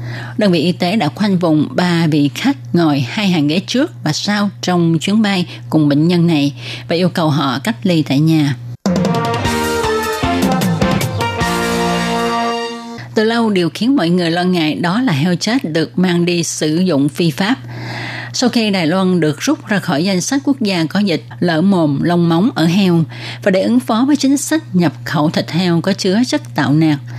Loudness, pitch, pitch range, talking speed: -15 LUFS, 175 Hz, 150-205 Hz, 190 wpm